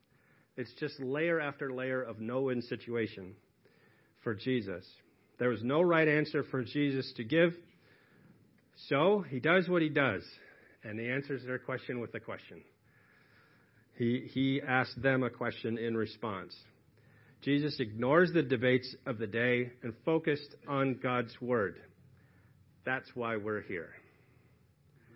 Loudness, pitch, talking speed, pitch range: -33 LUFS, 130 Hz, 135 wpm, 115-140 Hz